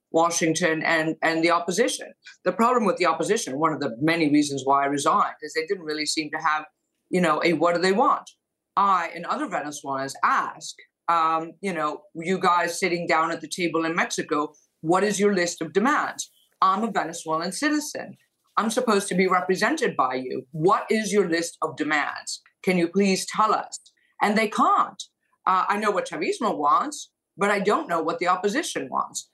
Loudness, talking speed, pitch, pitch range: -24 LUFS, 190 wpm, 175 Hz, 160-205 Hz